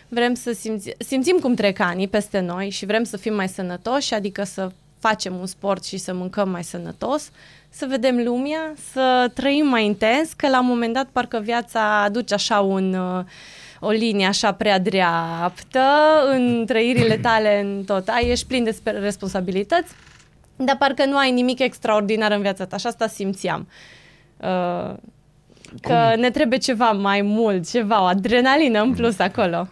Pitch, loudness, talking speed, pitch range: 220 Hz, -20 LUFS, 165 wpm, 195-250 Hz